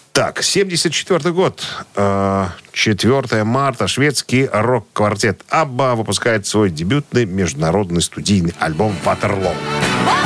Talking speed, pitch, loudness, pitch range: 90 wpm, 110 Hz, -16 LUFS, 95-135 Hz